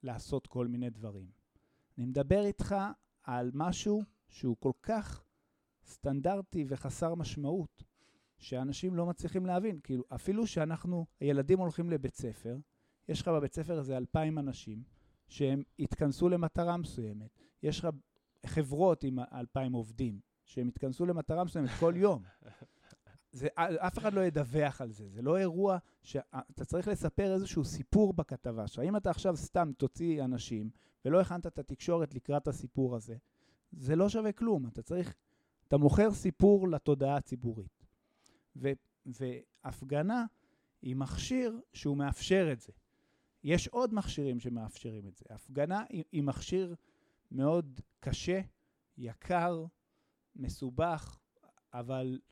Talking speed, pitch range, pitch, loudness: 125 wpm, 125-180 Hz, 145 Hz, -34 LUFS